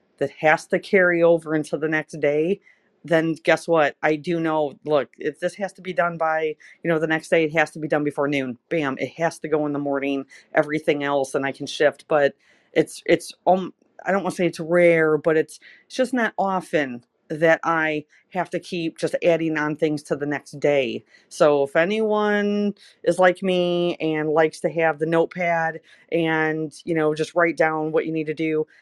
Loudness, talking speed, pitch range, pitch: -22 LUFS, 210 wpm, 155-175 Hz, 160 Hz